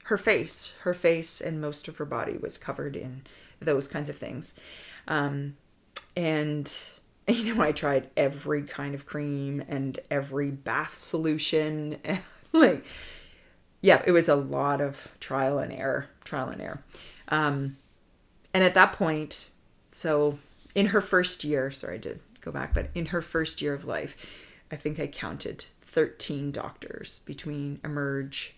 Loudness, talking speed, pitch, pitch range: -28 LUFS, 155 wpm, 150 Hz, 140-165 Hz